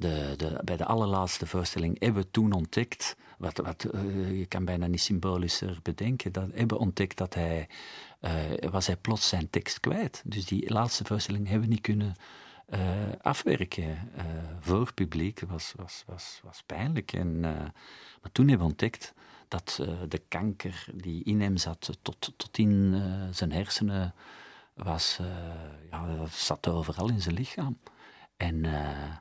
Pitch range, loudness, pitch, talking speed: 85-100 Hz, -31 LUFS, 90 Hz, 165 wpm